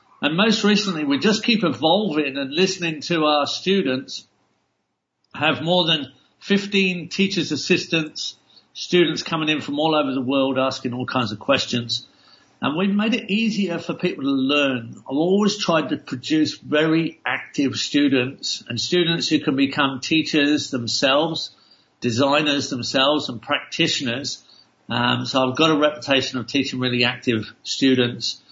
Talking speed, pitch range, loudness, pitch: 150 wpm, 135-175 Hz, -20 LUFS, 150 Hz